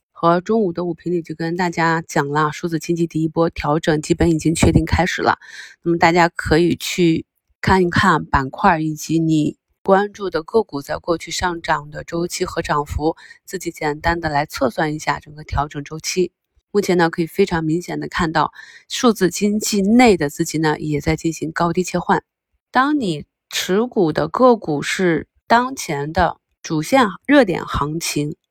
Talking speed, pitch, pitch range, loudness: 260 characters per minute, 170 Hz, 155-185 Hz, -19 LUFS